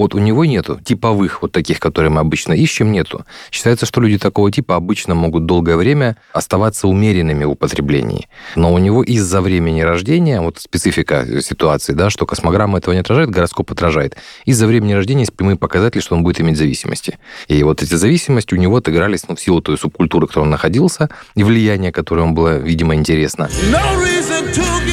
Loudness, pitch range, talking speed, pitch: -14 LUFS, 85-115 Hz, 185 wpm, 95 Hz